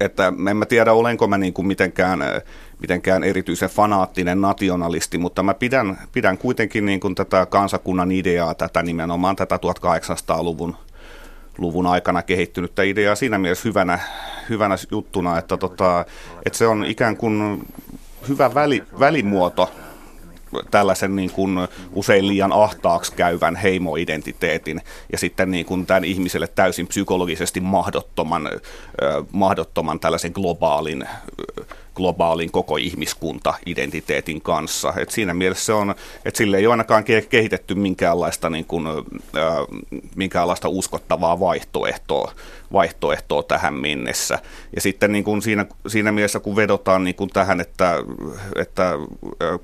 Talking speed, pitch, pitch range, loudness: 130 wpm, 95 Hz, 90-100 Hz, -20 LUFS